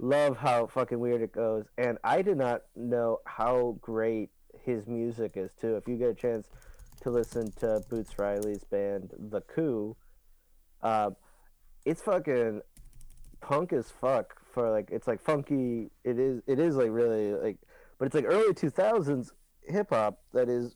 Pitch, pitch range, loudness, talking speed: 120 Hz, 110-125 Hz, -30 LUFS, 165 wpm